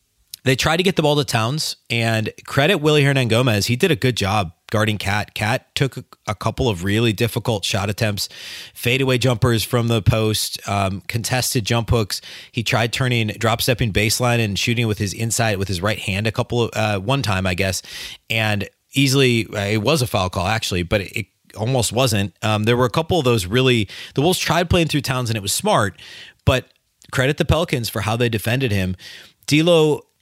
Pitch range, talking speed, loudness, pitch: 105-130 Hz, 205 wpm, -19 LUFS, 115 Hz